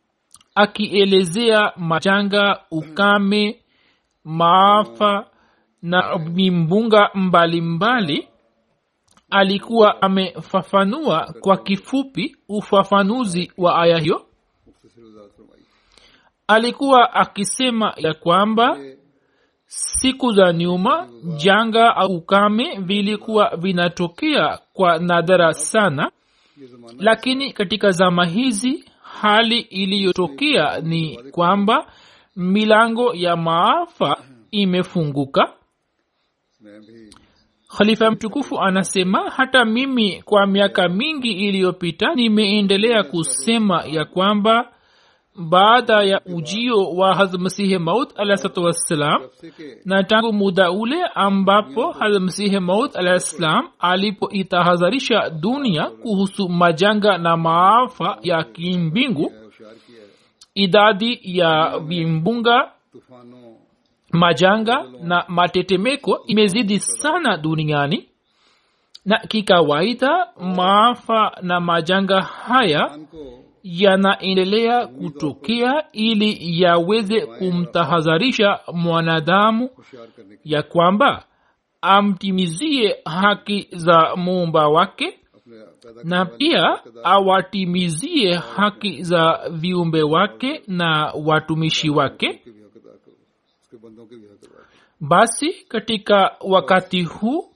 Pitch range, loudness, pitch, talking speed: 170-215 Hz, -17 LUFS, 195 Hz, 75 wpm